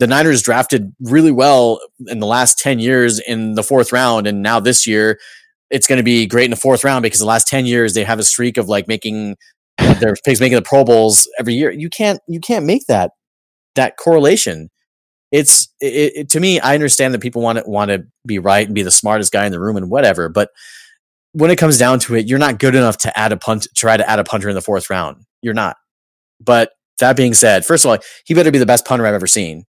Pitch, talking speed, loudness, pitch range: 120 Hz, 245 wpm, -13 LUFS, 110-130 Hz